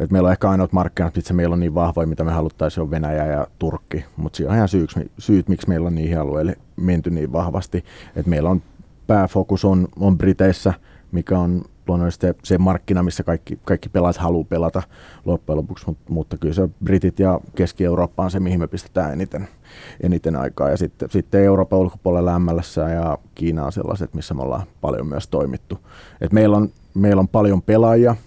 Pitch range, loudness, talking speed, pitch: 85-95 Hz, -20 LUFS, 195 wpm, 90 Hz